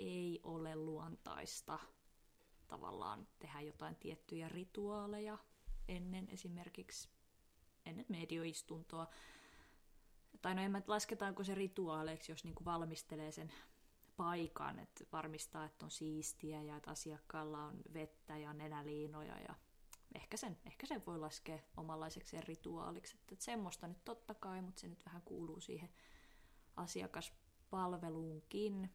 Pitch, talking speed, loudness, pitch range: 165 Hz, 115 wpm, -49 LUFS, 155-190 Hz